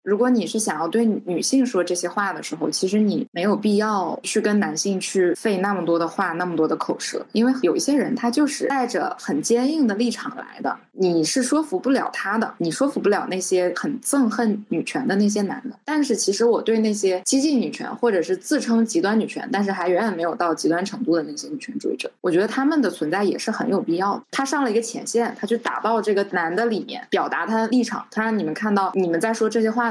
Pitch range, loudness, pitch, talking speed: 195-255 Hz, -22 LUFS, 225 Hz, 355 characters per minute